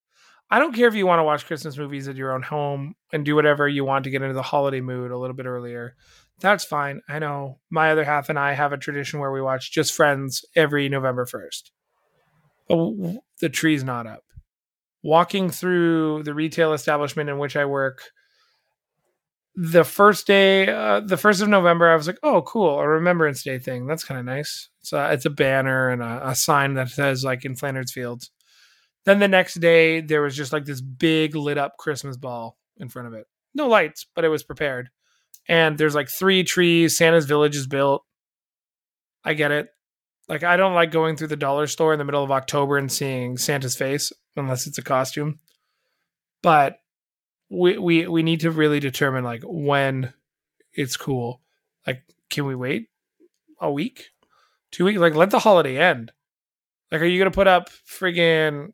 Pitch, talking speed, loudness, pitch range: 150 Hz, 195 wpm, -21 LUFS, 135-170 Hz